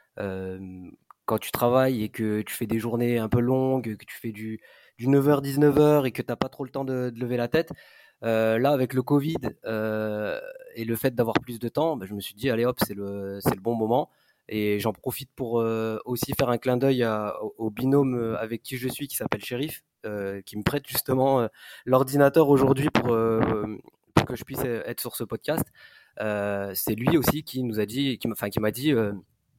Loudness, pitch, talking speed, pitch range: -26 LUFS, 120 Hz, 230 wpm, 110-135 Hz